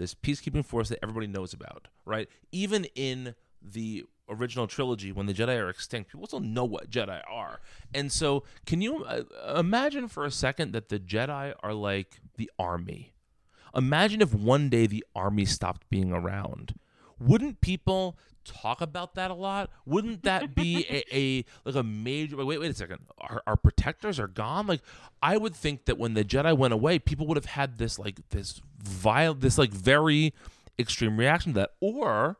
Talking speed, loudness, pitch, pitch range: 180 wpm, -29 LUFS, 130 Hz, 105-155 Hz